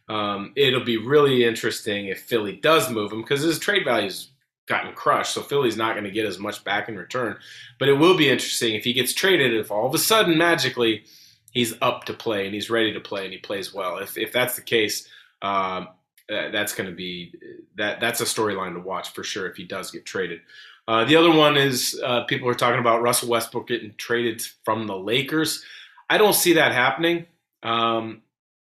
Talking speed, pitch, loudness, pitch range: 210 wpm, 120 Hz, -22 LUFS, 110-155 Hz